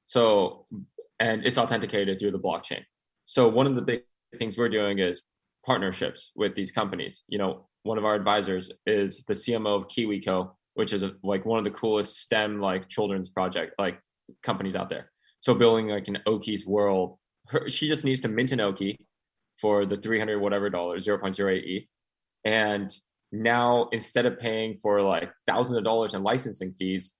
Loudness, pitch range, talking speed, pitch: -27 LUFS, 100-115 Hz, 180 wpm, 105 Hz